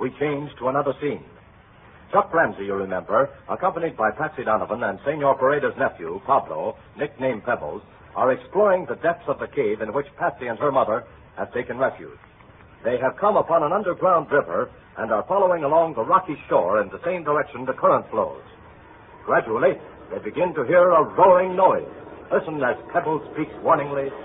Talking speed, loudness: 175 wpm, -22 LUFS